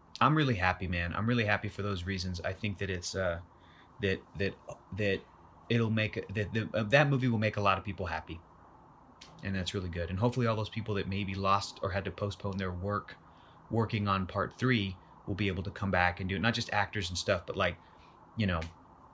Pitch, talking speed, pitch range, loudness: 100 Hz, 225 wpm, 90-110 Hz, -32 LUFS